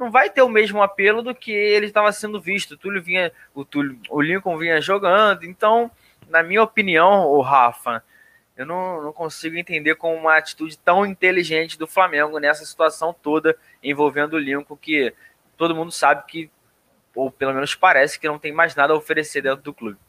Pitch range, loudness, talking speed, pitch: 150-195 Hz, -19 LUFS, 190 wpm, 160 Hz